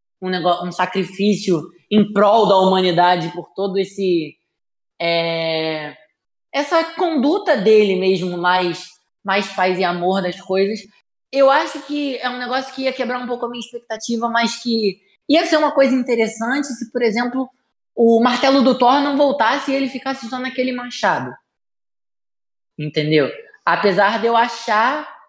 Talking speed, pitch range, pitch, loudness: 150 wpm, 185-260 Hz, 225 Hz, -18 LUFS